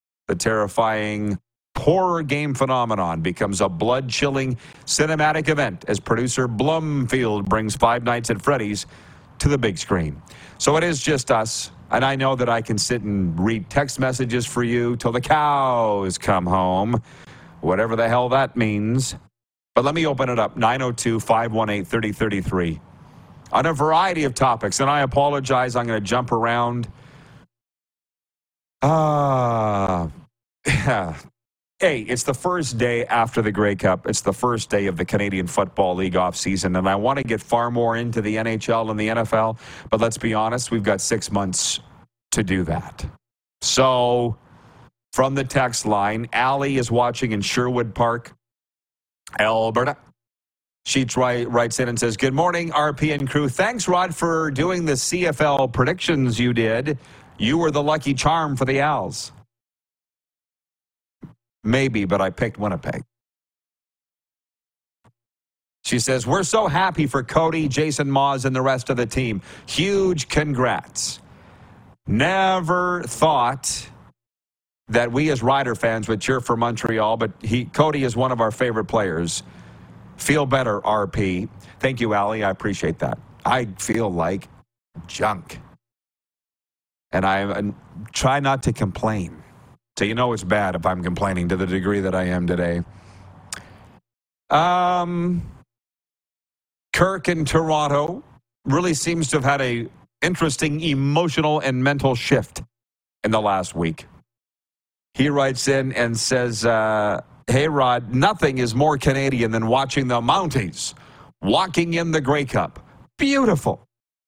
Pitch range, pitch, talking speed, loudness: 105-140 Hz, 120 Hz, 145 wpm, -21 LUFS